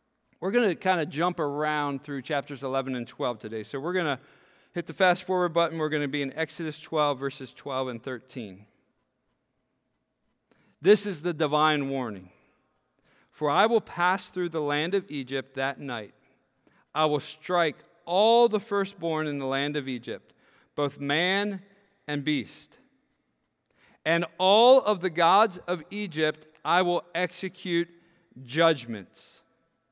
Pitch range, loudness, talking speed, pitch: 140-180 Hz, -27 LUFS, 150 wpm, 155 Hz